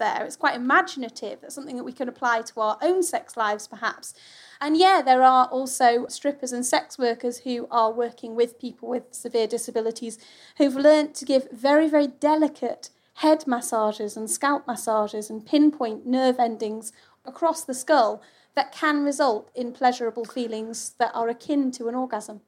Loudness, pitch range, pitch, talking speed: -23 LUFS, 230-285 Hz, 245 Hz, 170 wpm